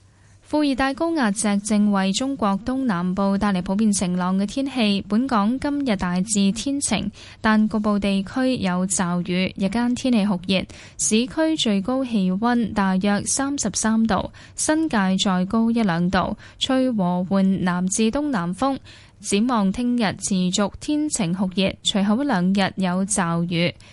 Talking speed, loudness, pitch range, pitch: 225 characters per minute, -21 LUFS, 190-240 Hz, 205 Hz